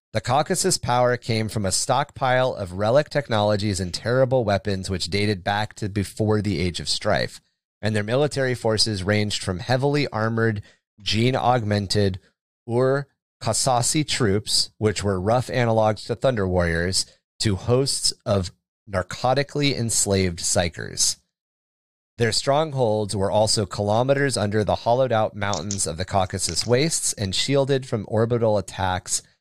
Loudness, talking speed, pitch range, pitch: -22 LUFS, 135 wpm, 100-125 Hz, 110 Hz